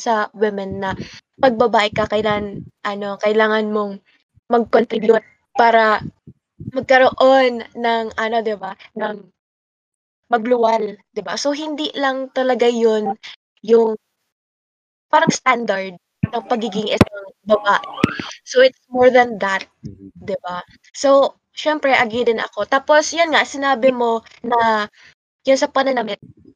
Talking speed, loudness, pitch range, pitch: 120 wpm, -17 LUFS, 210-255 Hz, 225 Hz